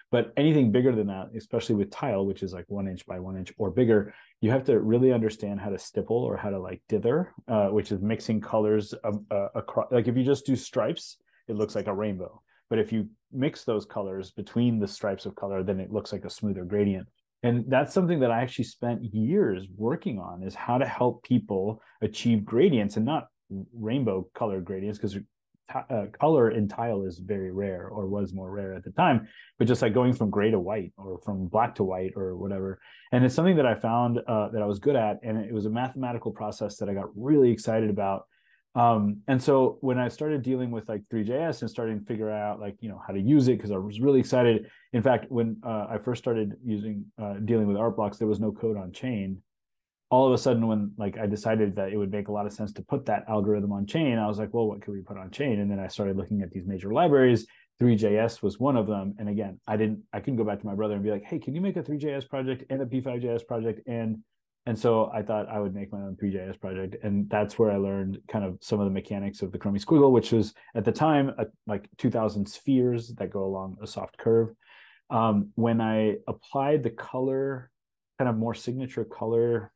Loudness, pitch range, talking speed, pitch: -27 LUFS, 100-120 Hz, 240 wpm, 110 Hz